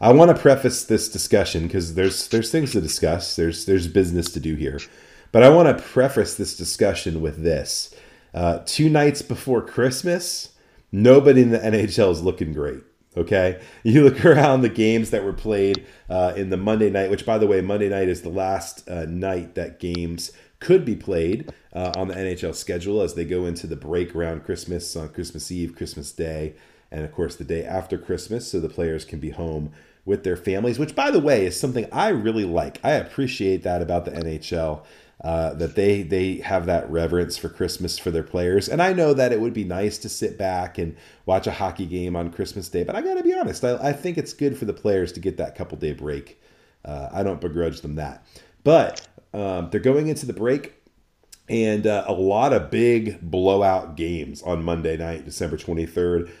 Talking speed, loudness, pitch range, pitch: 205 wpm, -21 LUFS, 85-115 Hz, 95 Hz